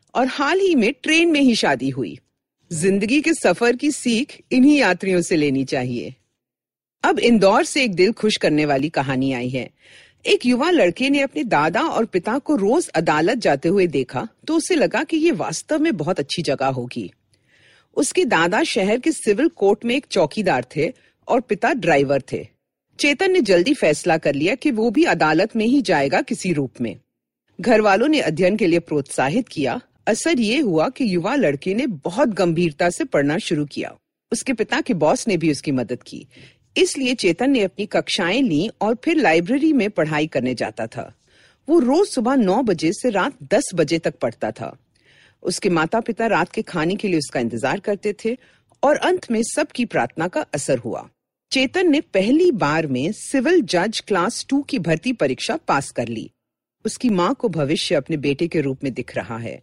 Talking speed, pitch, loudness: 190 wpm, 215 Hz, -19 LUFS